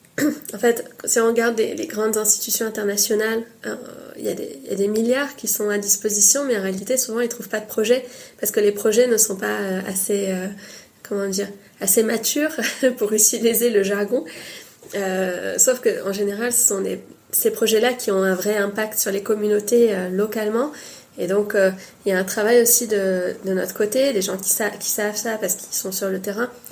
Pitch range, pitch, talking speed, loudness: 200-235 Hz, 215 Hz, 210 wpm, -20 LUFS